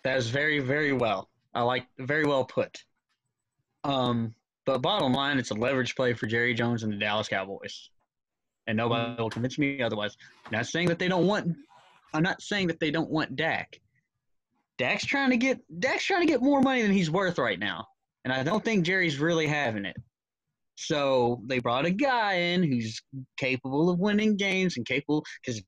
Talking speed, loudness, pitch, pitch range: 190 wpm, -27 LUFS, 140 Hz, 120-170 Hz